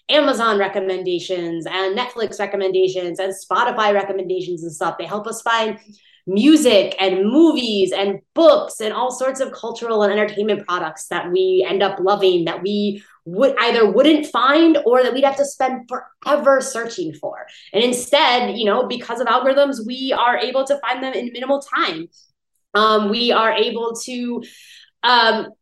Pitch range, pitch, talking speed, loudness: 195-260 Hz, 225 Hz, 160 wpm, -18 LUFS